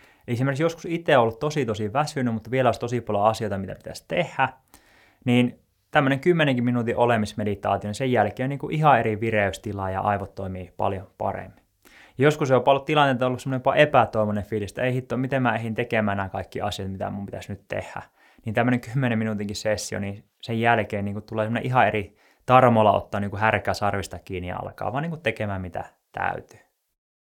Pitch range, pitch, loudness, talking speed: 100-125 Hz, 110 Hz, -24 LUFS, 185 wpm